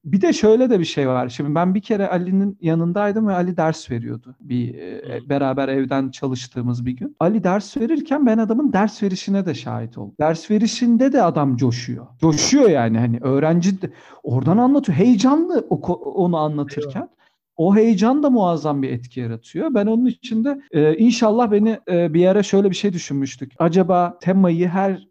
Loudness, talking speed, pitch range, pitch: -18 LUFS, 170 wpm, 140-215 Hz, 180 Hz